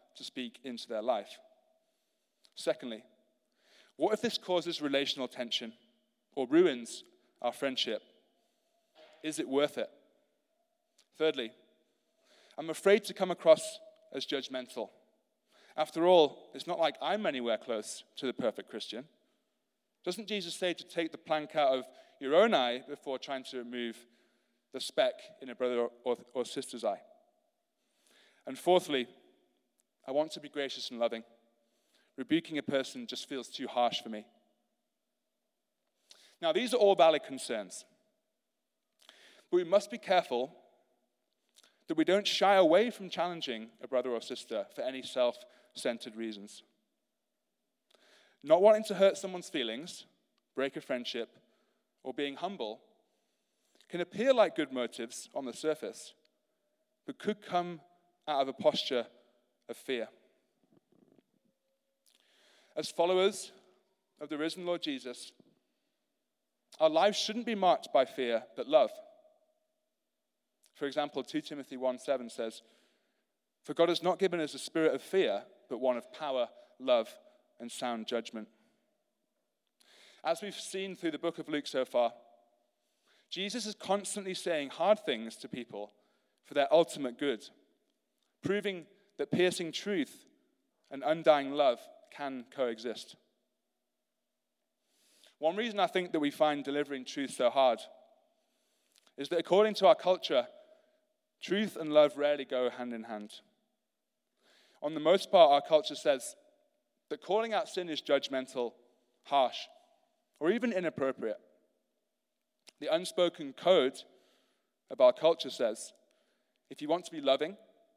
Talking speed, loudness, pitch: 135 wpm, -32 LUFS, 175 Hz